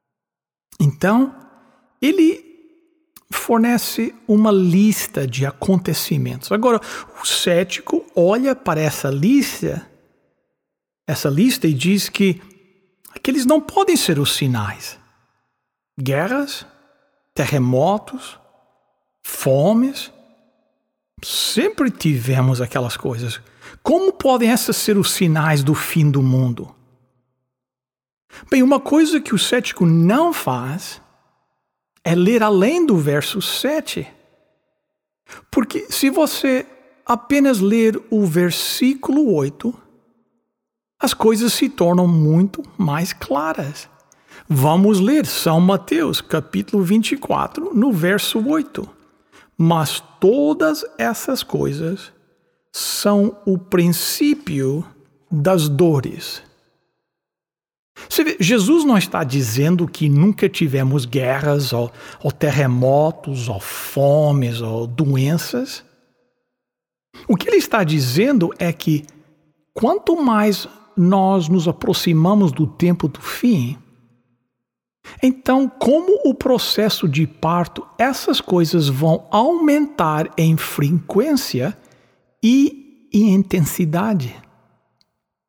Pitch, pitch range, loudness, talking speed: 190 Hz, 150-255 Hz, -17 LUFS, 95 wpm